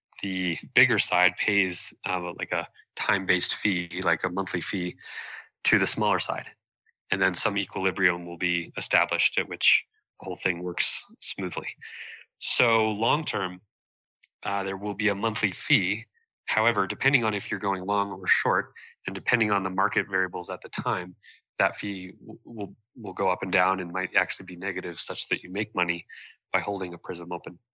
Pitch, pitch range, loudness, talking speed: 95 Hz, 90-100 Hz, -25 LUFS, 180 wpm